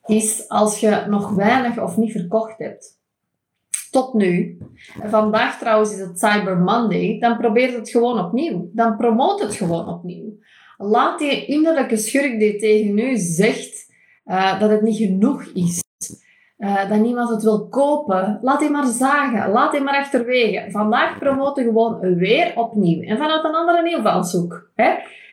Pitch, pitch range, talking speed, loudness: 220 Hz, 205-255 Hz, 155 wpm, -18 LUFS